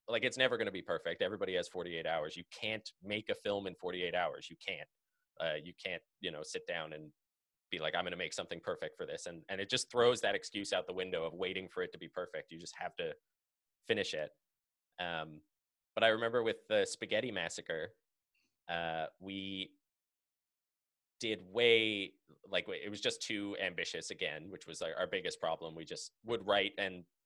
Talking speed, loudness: 205 wpm, -38 LUFS